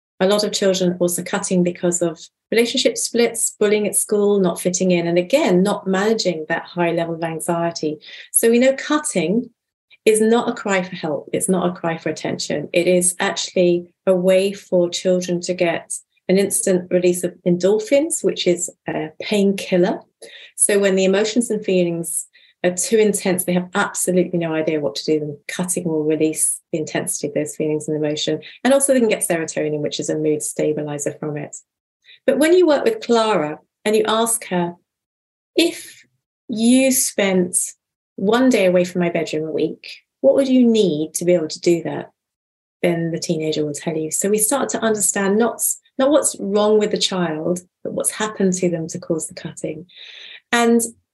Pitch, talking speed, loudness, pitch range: 180 Hz, 185 wpm, -19 LUFS, 170-215 Hz